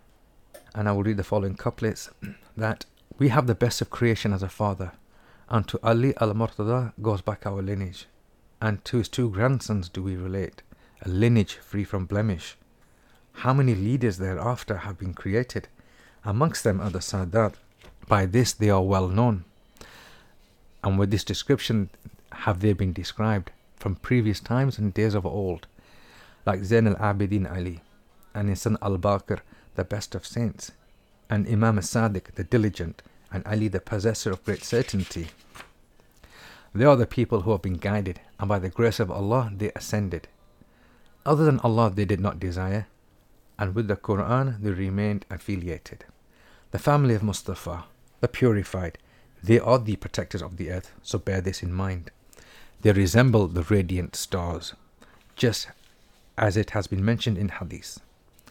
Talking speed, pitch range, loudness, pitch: 160 wpm, 95-115 Hz, -26 LUFS, 105 Hz